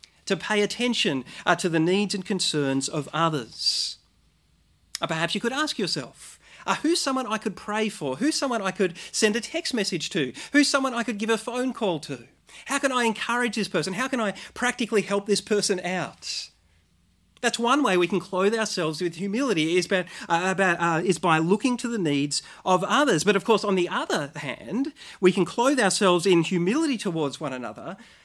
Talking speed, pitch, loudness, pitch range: 195 wpm, 195 Hz, -25 LUFS, 165-235 Hz